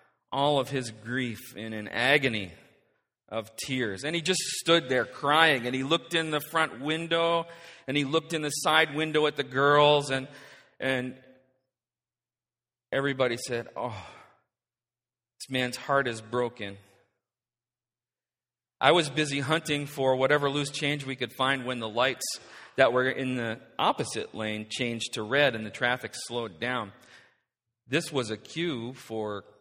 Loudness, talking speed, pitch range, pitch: -28 LUFS, 150 wpm, 120-145 Hz, 130 Hz